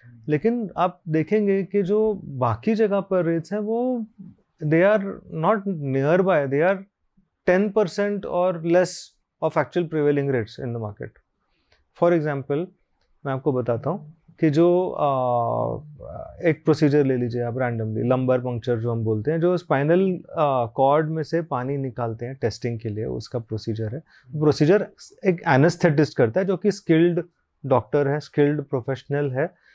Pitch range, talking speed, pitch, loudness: 130-180 Hz, 155 wpm, 155 Hz, -23 LUFS